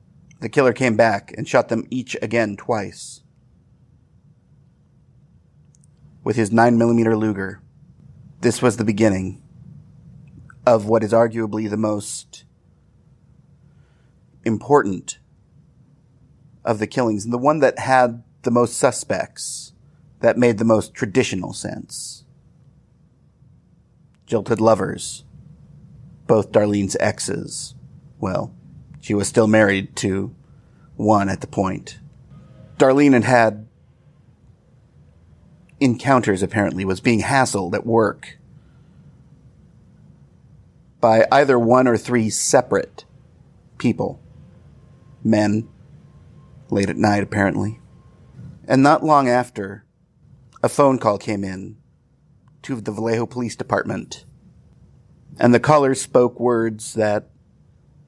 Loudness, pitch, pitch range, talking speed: -19 LUFS, 120 Hz, 105-135 Hz, 105 wpm